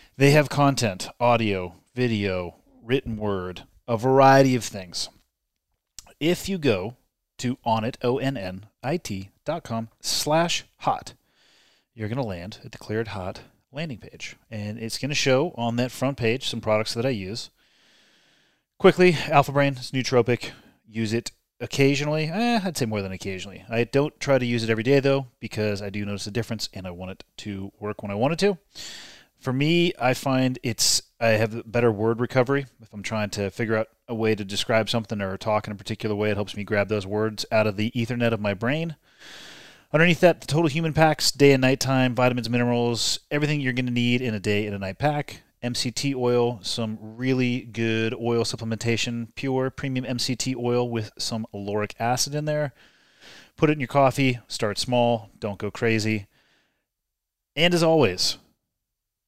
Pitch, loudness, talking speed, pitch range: 115 Hz, -24 LUFS, 180 wpm, 105-135 Hz